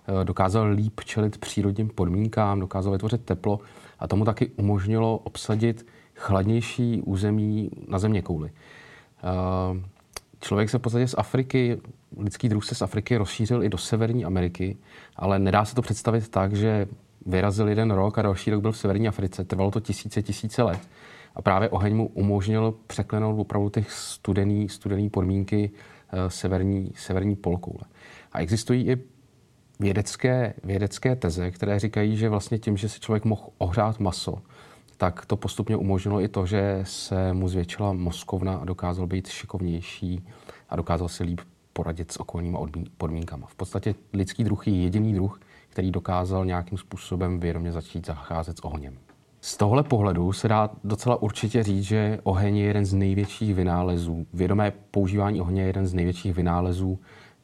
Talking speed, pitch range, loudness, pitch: 155 wpm, 95-110 Hz, -26 LUFS, 100 Hz